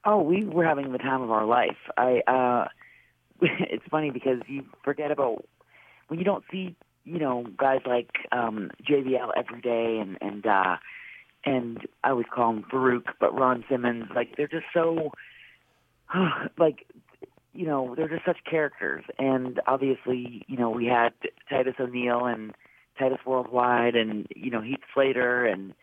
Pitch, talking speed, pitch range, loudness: 130 Hz, 160 wpm, 120-145 Hz, -27 LUFS